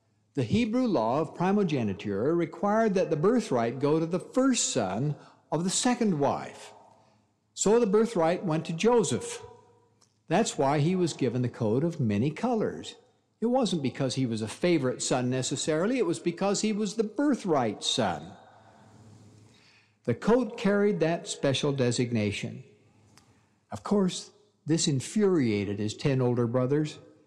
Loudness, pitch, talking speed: -27 LUFS, 155 Hz, 145 wpm